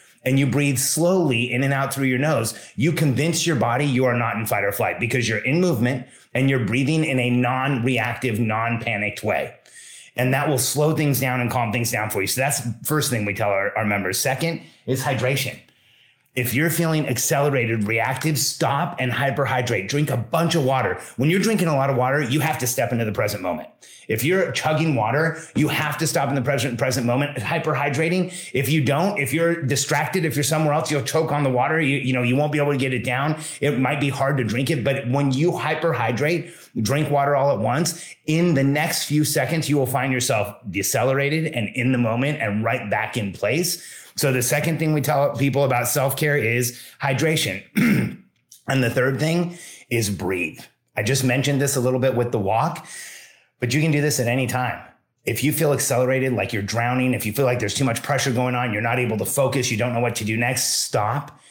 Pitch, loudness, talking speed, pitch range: 135 Hz, -21 LUFS, 220 wpm, 120-150 Hz